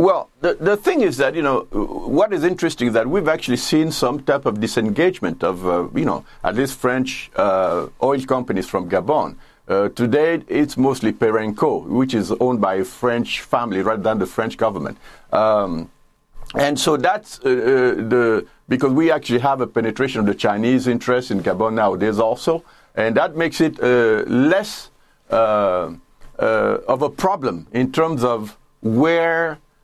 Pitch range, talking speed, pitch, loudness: 110-155 Hz, 170 wpm, 125 Hz, -19 LUFS